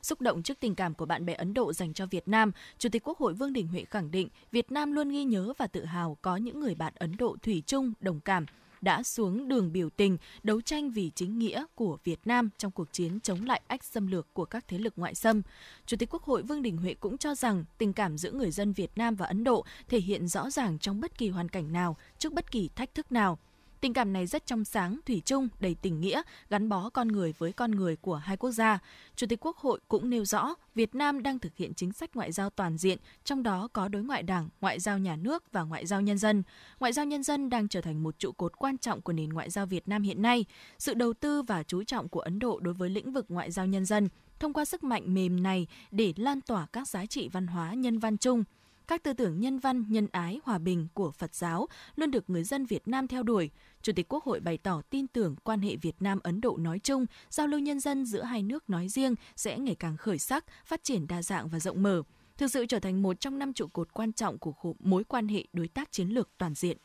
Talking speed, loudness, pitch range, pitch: 260 wpm, -32 LUFS, 180-245 Hz, 210 Hz